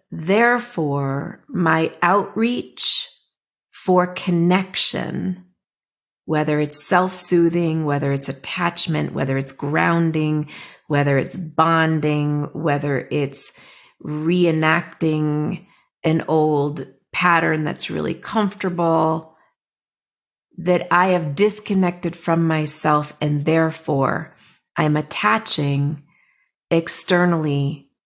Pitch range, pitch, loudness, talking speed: 150-180 Hz, 160 Hz, -20 LUFS, 80 wpm